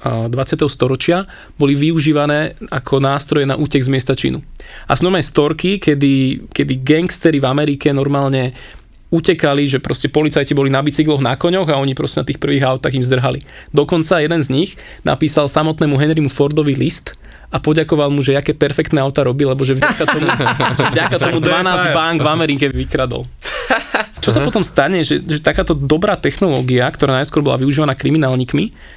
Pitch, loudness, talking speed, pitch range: 145 Hz, -15 LUFS, 170 wpm, 135-155 Hz